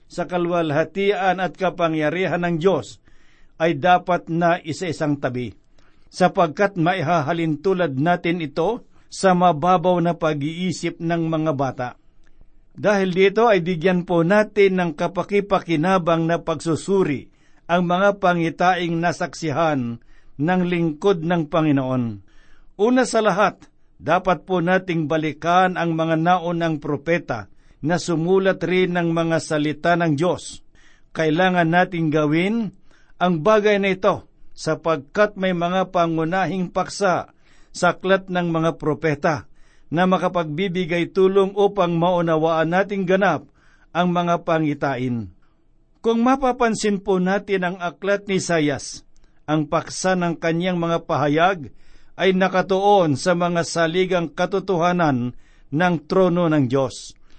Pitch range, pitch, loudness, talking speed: 160-185 Hz, 175 Hz, -20 LUFS, 115 wpm